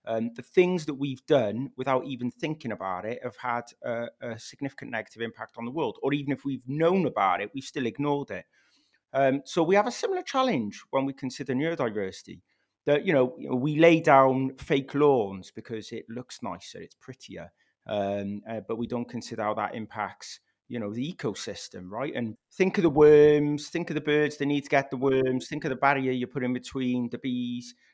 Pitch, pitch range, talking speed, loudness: 130 Hz, 120-150 Hz, 210 wpm, -27 LUFS